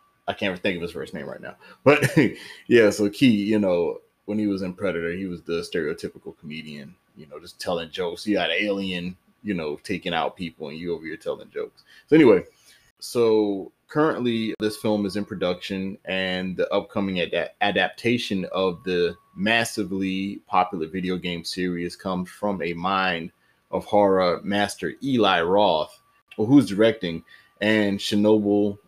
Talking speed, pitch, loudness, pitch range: 165 wpm, 100 Hz, -23 LUFS, 90-110 Hz